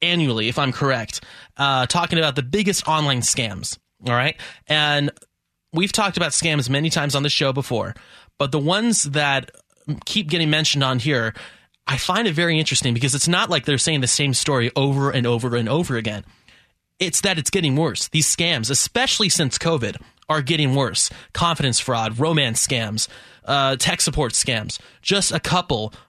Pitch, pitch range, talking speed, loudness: 145 Hz, 125-165 Hz, 175 wpm, -19 LUFS